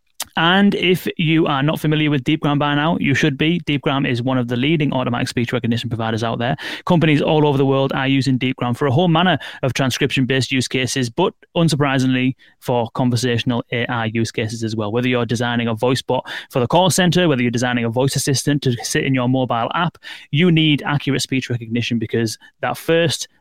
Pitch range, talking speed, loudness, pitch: 120-155 Hz, 210 wpm, -18 LUFS, 135 Hz